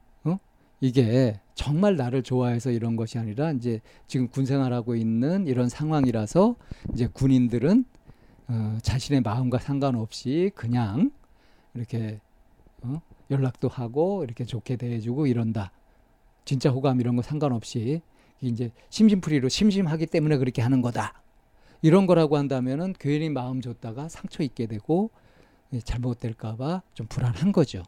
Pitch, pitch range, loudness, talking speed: 130 Hz, 120-150 Hz, -26 LUFS, 300 characters per minute